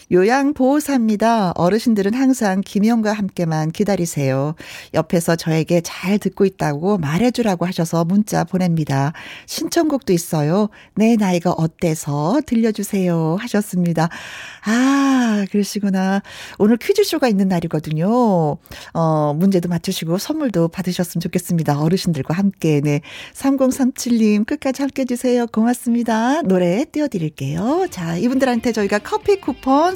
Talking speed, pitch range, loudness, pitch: 320 characters per minute, 170-245 Hz, -18 LUFS, 200 Hz